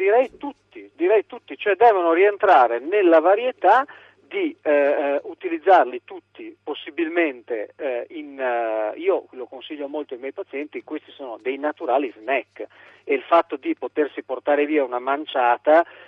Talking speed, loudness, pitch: 140 wpm, -21 LUFS, 195 Hz